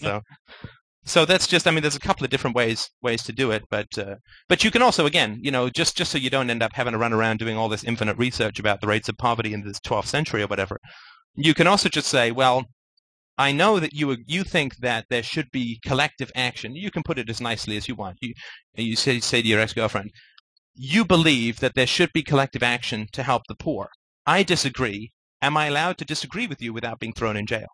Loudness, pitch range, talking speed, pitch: -22 LUFS, 115-150 Hz, 240 wpm, 125 Hz